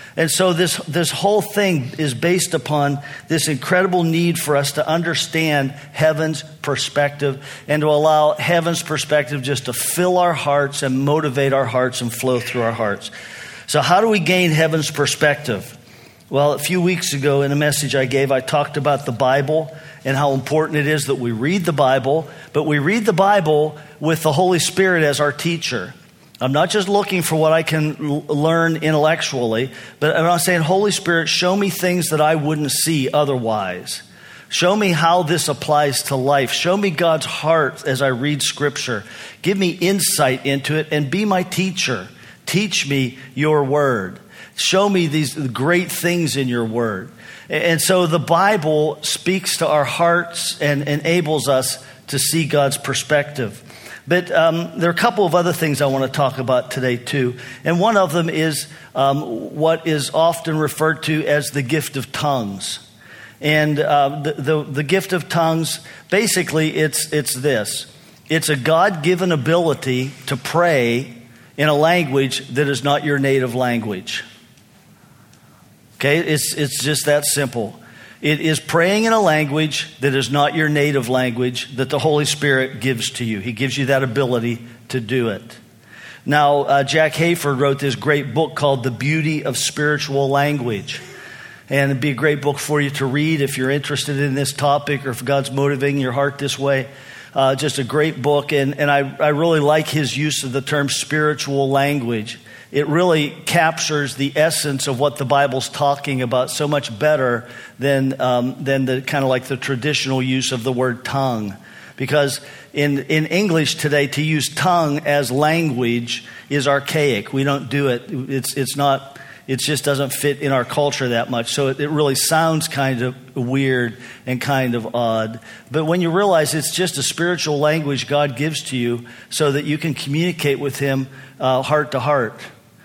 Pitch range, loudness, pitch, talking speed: 135-160 Hz, -18 LUFS, 145 Hz, 180 wpm